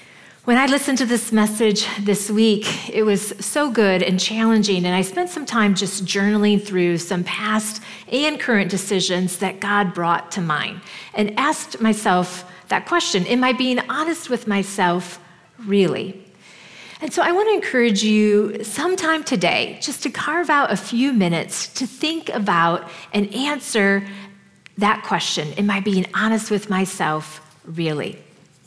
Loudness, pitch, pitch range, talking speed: -19 LUFS, 205 Hz, 185-240 Hz, 155 wpm